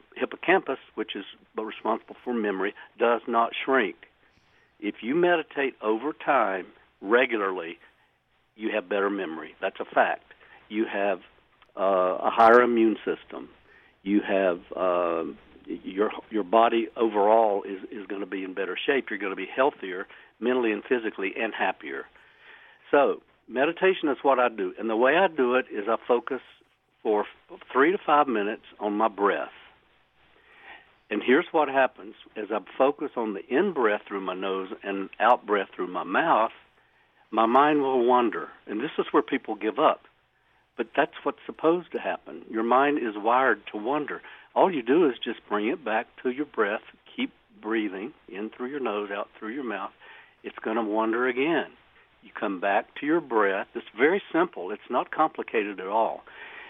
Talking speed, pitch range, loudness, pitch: 170 wpm, 105-140 Hz, -26 LUFS, 115 Hz